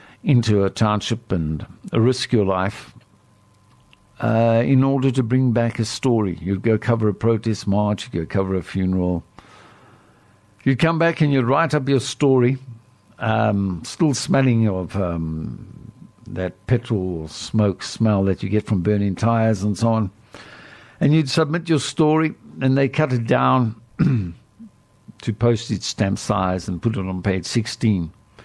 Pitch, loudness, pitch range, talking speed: 110 Hz, -20 LUFS, 100-130 Hz, 155 wpm